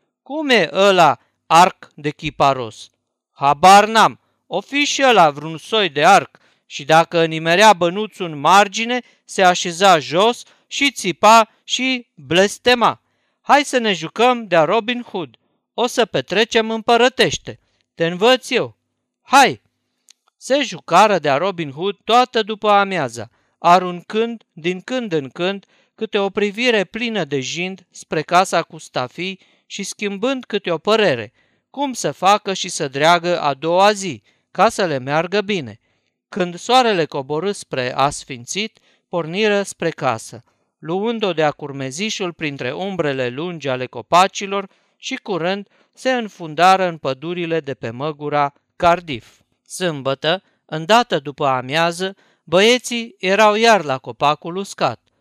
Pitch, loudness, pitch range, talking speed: 180 Hz, -17 LUFS, 150-215 Hz, 135 wpm